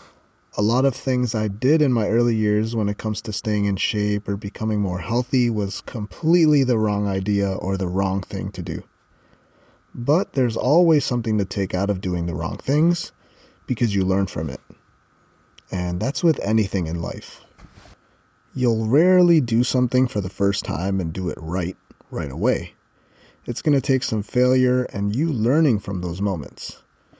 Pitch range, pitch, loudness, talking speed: 95-125 Hz, 105 Hz, -22 LUFS, 175 wpm